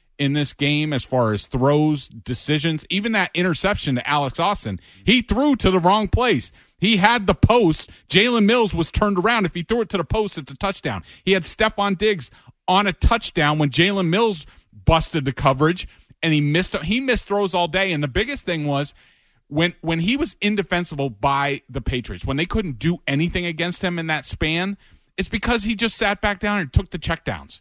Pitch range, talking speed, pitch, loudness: 145-200 Hz, 205 wpm, 170 Hz, -20 LUFS